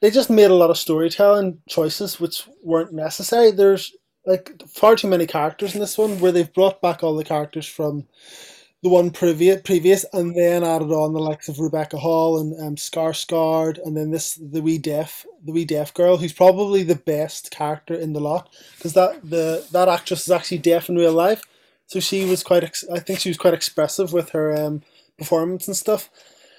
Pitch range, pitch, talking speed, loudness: 160-185 Hz, 170 Hz, 205 wpm, -19 LUFS